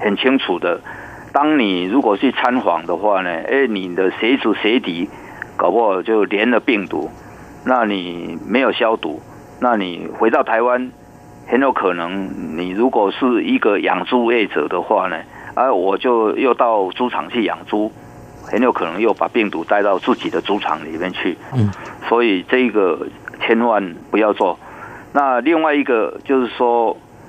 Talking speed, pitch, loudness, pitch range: 230 characters per minute, 105 Hz, -17 LUFS, 85-125 Hz